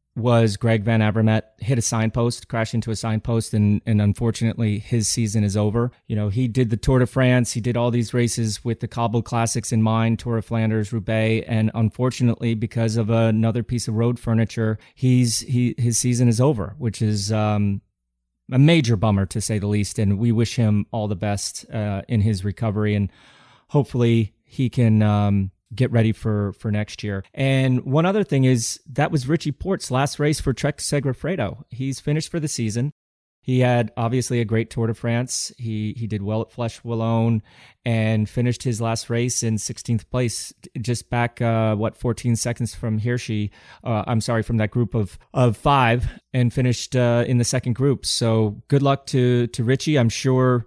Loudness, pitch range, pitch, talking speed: -22 LUFS, 110-125 Hz, 115 Hz, 190 wpm